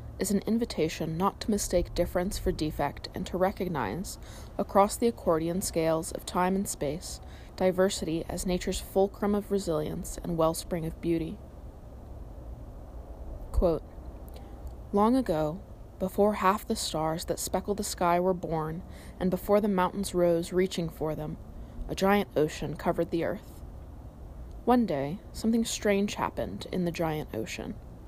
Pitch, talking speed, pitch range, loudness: 175 Hz, 140 wpm, 155-195 Hz, -29 LUFS